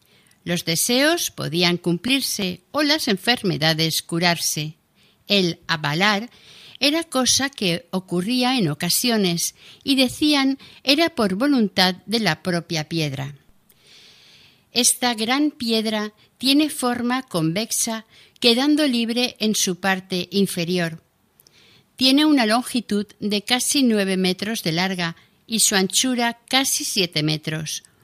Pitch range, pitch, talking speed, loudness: 175-250 Hz, 210 Hz, 110 wpm, -20 LUFS